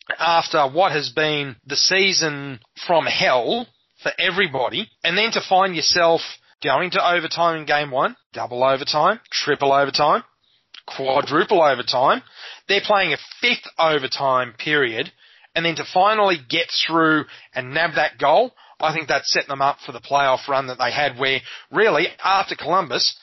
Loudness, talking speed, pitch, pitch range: -19 LUFS, 155 wpm, 155 Hz, 140-170 Hz